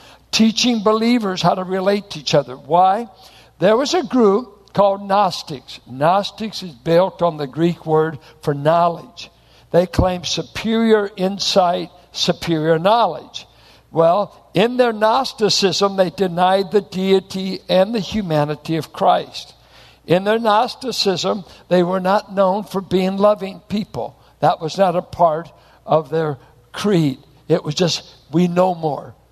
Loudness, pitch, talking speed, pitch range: -18 LUFS, 185 Hz, 140 wpm, 160-200 Hz